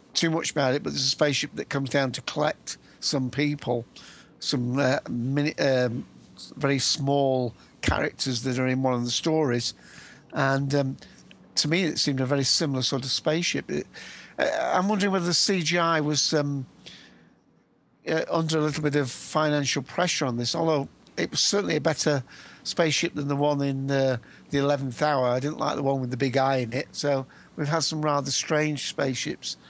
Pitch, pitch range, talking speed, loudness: 140 Hz, 130-155 Hz, 190 wpm, -25 LUFS